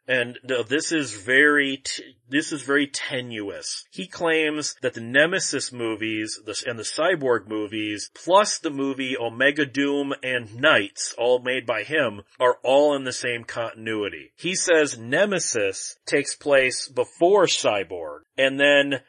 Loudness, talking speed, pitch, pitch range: -23 LUFS, 150 wpm, 135 Hz, 120-150 Hz